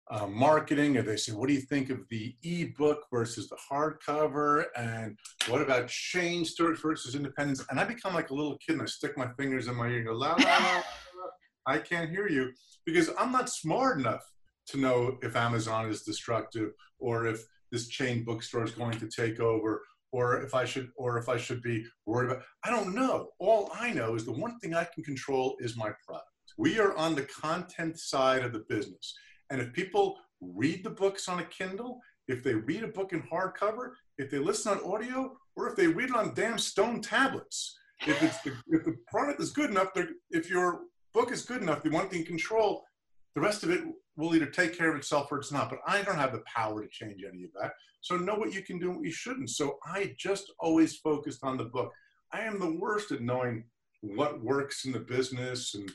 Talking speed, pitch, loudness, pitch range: 225 wpm, 150 Hz, -31 LUFS, 125-195 Hz